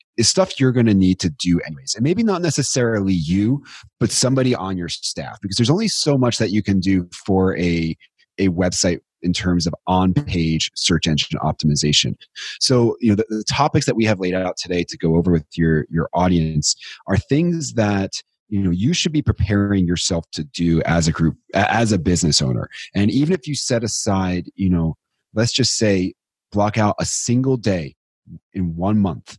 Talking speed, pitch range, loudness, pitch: 200 wpm, 85-120 Hz, -19 LUFS, 95 Hz